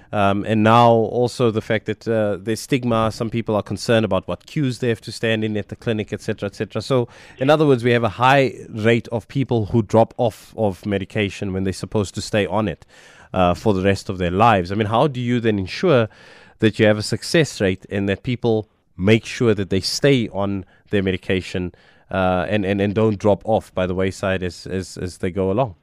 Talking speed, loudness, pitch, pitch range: 230 wpm, -20 LUFS, 110 Hz, 95-115 Hz